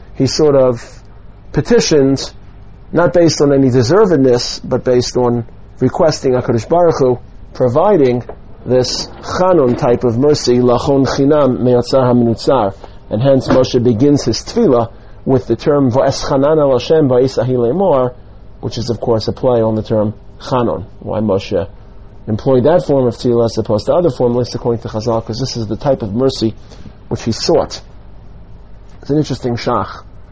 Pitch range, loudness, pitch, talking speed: 110-130 Hz, -13 LUFS, 120 Hz, 150 wpm